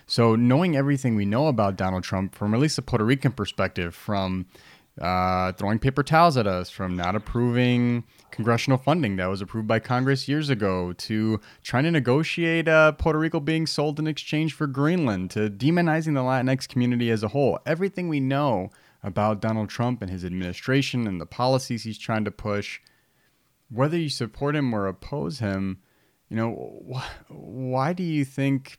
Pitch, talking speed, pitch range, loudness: 120 Hz, 175 wpm, 105-145 Hz, -24 LUFS